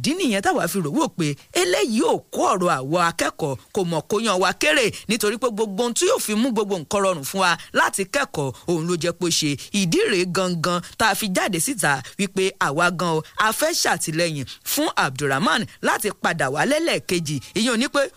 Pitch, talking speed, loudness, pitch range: 195 Hz, 215 wpm, -21 LUFS, 175-225 Hz